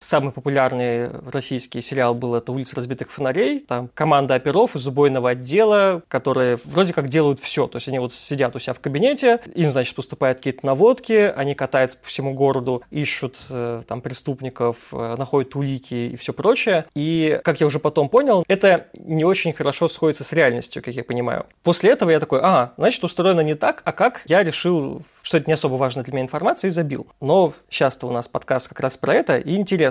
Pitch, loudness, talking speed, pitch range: 140 Hz, -20 LUFS, 195 wpm, 130-160 Hz